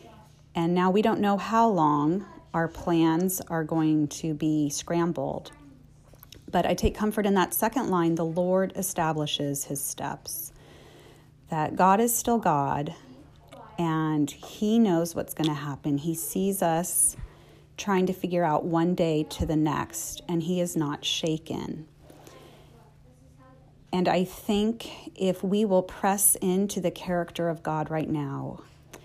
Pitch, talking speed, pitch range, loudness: 170 Hz, 145 wpm, 150-185 Hz, -26 LUFS